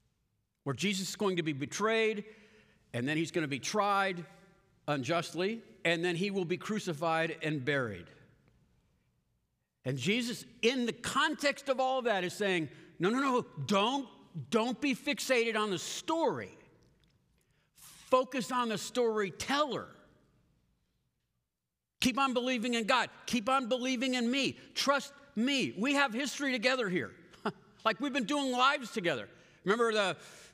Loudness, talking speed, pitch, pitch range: -32 LUFS, 145 wpm, 215 Hz, 170-255 Hz